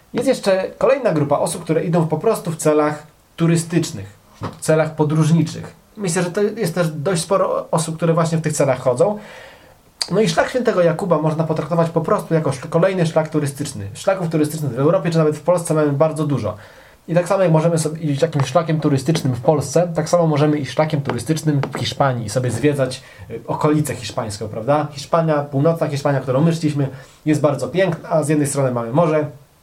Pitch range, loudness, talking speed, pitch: 145-170 Hz, -18 LUFS, 190 wpm, 155 Hz